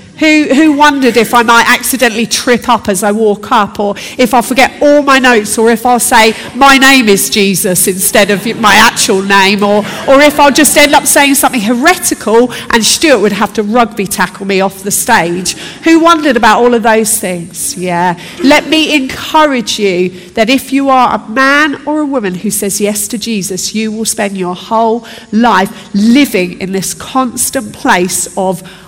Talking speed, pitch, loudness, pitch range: 195 wpm, 225 Hz, -8 LUFS, 200-265 Hz